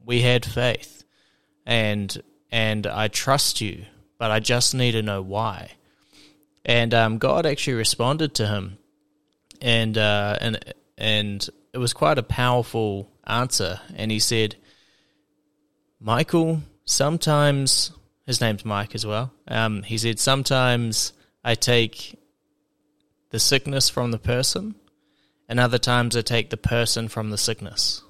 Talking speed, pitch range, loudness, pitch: 135 wpm, 110-135 Hz, -22 LUFS, 120 Hz